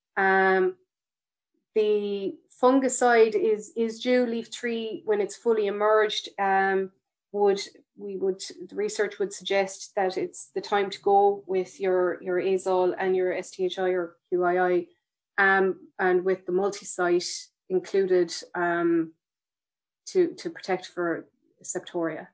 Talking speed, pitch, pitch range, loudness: 125 wpm, 195 Hz, 185-245 Hz, -26 LUFS